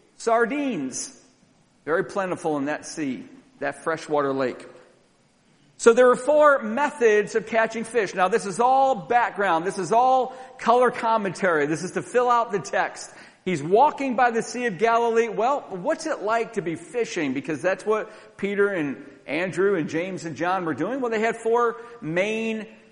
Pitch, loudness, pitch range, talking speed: 225 Hz, -23 LUFS, 185-245 Hz, 170 wpm